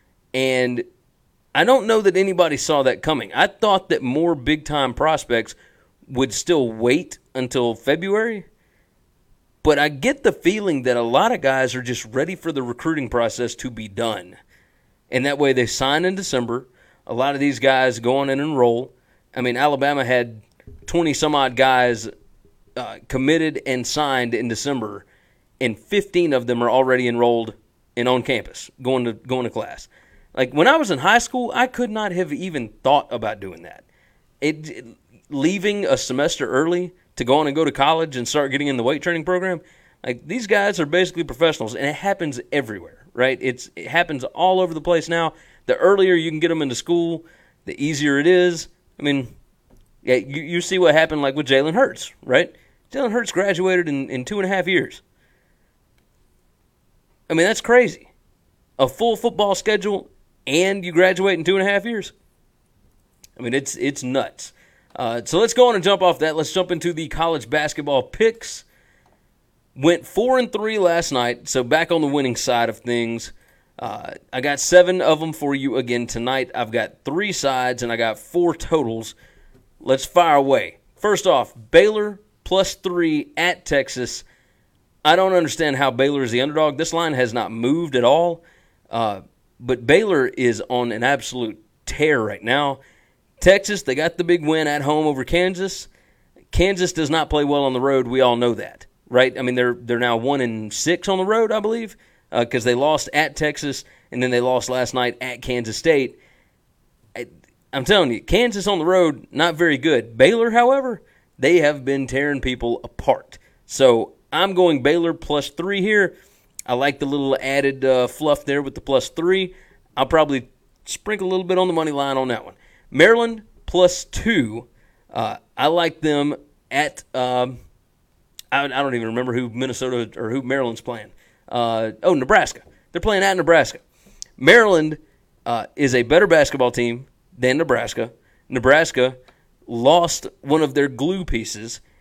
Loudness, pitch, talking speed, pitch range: -19 LUFS, 145 Hz, 180 wpm, 125-175 Hz